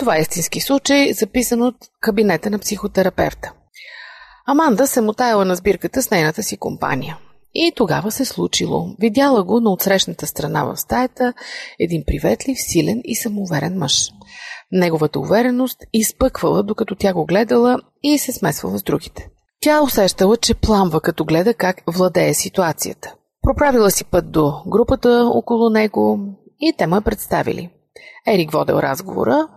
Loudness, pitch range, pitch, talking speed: -17 LUFS, 185-250 Hz, 215 Hz, 140 wpm